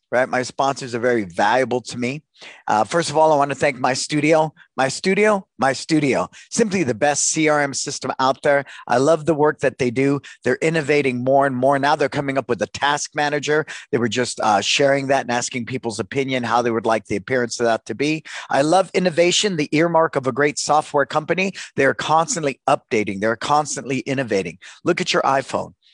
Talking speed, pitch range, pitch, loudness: 205 wpm, 130-155 Hz, 140 Hz, -19 LUFS